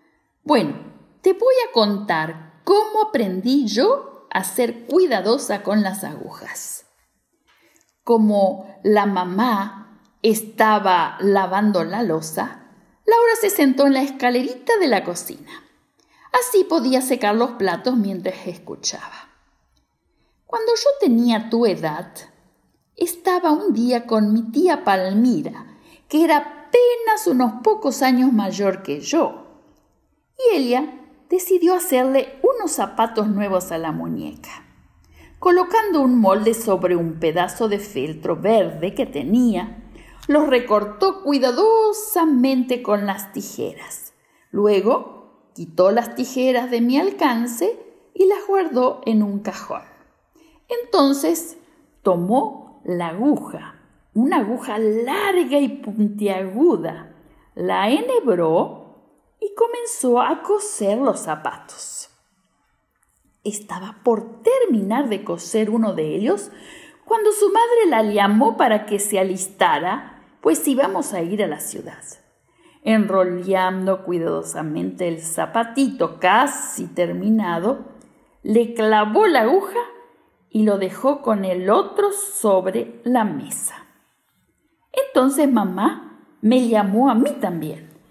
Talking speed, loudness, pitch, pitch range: 110 wpm, -19 LUFS, 245 Hz, 205-320 Hz